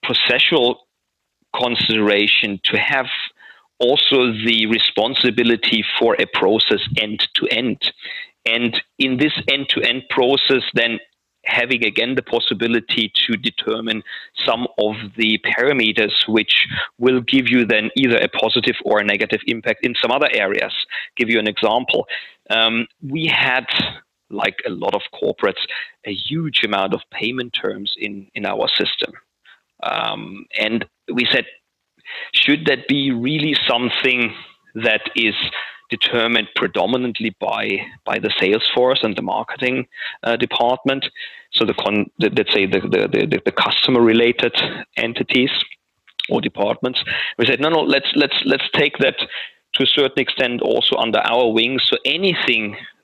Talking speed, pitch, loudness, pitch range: 145 wpm, 120 Hz, -17 LUFS, 110-130 Hz